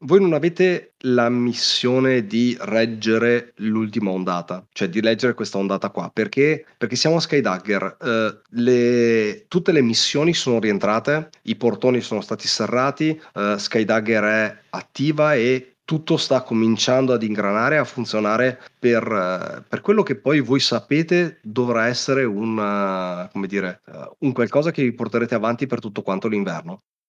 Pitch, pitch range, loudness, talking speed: 120 Hz, 110-135 Hz, -20 LUFS, 150 wpm